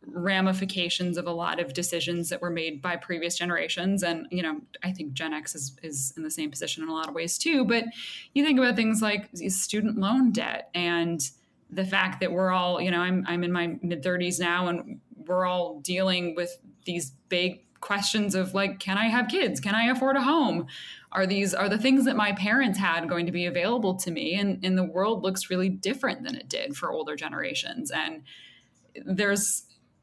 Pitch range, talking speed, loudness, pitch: 175-205 Hz, 205 wpm, -27 LUFS, 185 Hz